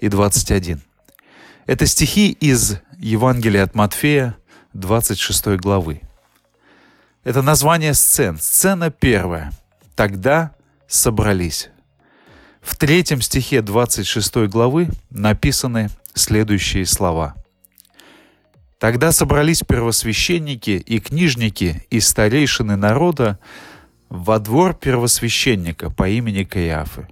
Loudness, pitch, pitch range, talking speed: -16 LUFS, 110 Hz, 95-135 Hz, 85 wpm